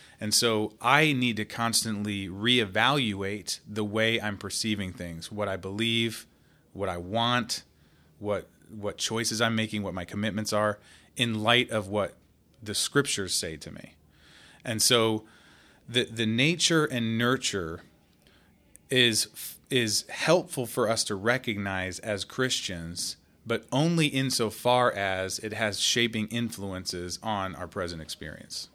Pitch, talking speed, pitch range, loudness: 110 Hz, 135 wpm, 100-120 Hz, -27 LUFS